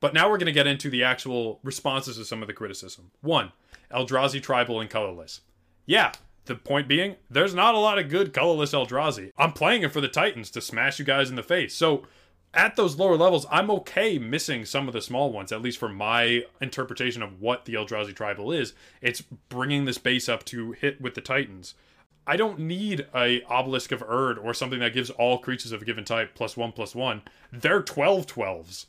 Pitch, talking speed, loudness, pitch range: 125 Hz, 215 wpm, -25 LUFS, 115-140 Hz